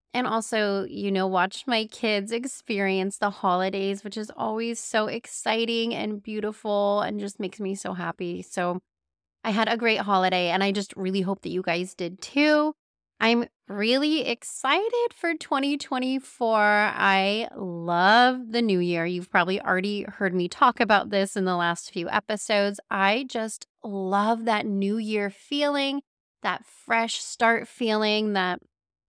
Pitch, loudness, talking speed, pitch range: 210 Hz, -25 LUFS, 155 wpm, 190-230 Hz